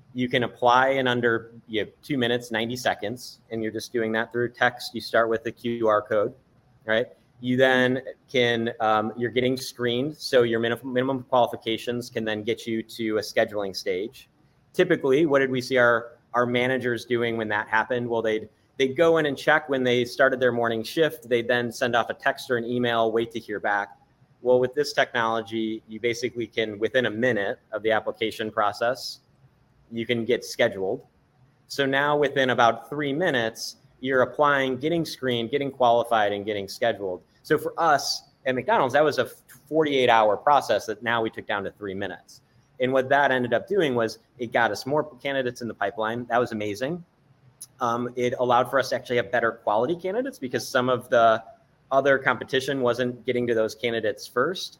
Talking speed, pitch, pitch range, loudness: 190 wpm, 120 Hz, 115-130 Hz, -24 LUFS